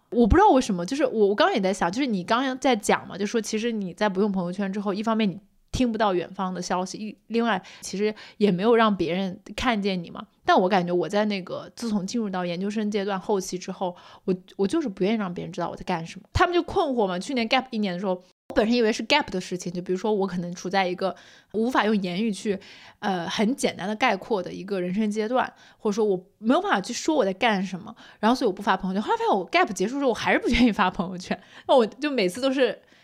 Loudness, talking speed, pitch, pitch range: -25 LUFS, 395 characters per minute, 210 Hz, 190-235 Hz